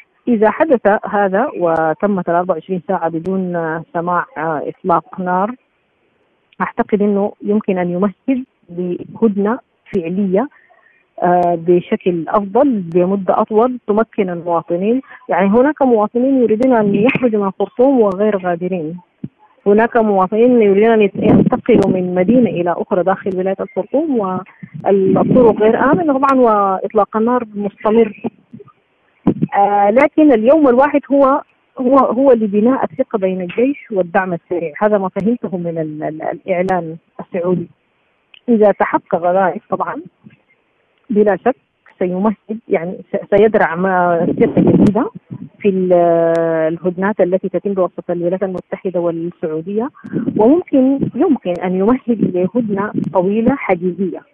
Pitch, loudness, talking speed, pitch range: 200 Hz, -15 LUFS, 105 wpm, 180-235 Hz